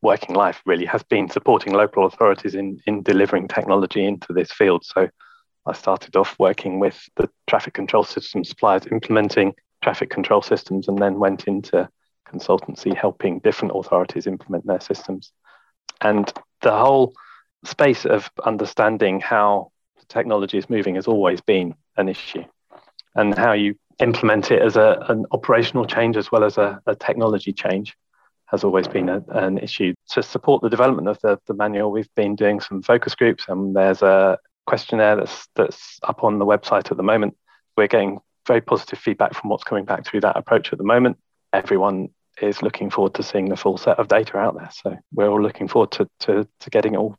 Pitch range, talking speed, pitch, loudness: 95-105 Hz, 185 wpm, 100 Hz, -20 LUFS